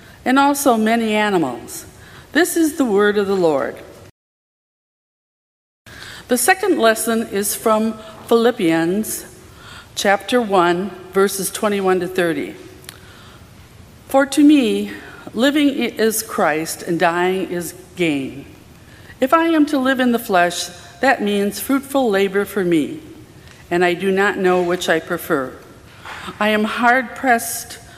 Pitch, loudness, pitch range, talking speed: 210 Hz, -17 LUFS, 180-255 Hz, 125 wpm